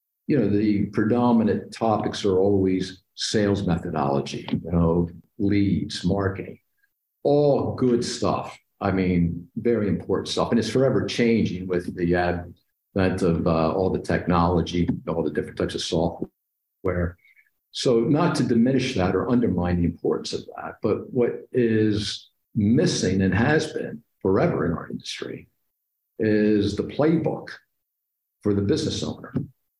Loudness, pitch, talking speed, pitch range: -23 LUFS, 100 Hz, 135 wpm, 90-115 Hz